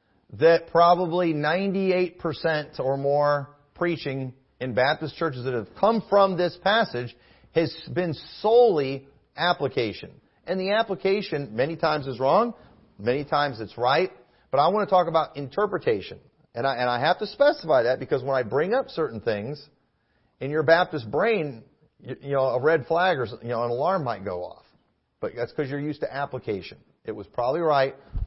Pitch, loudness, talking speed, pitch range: 150 Hz, -24 LUFS, 170 wpm, 130-175 Hz